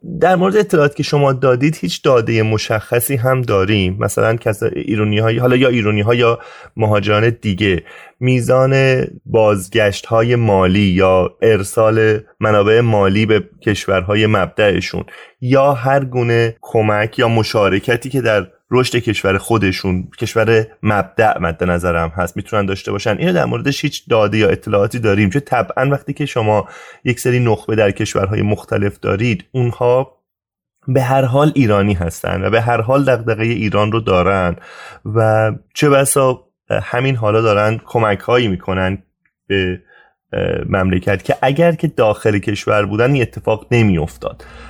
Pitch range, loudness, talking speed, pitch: 100-125 Hz, -15 LUFS, 145 wpm, 110 Hz